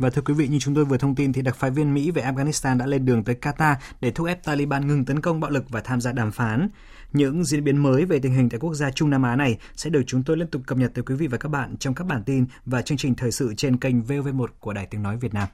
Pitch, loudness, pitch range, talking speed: 135 Hz, -23 LUFS, 125-145 Hz, 315 wpm